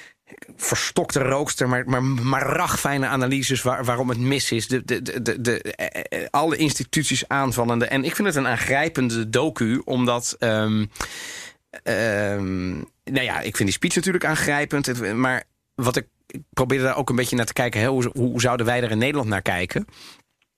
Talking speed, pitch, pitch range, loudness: 180 wpm, 125 Hz, 120-135 Hz, -22 LUFS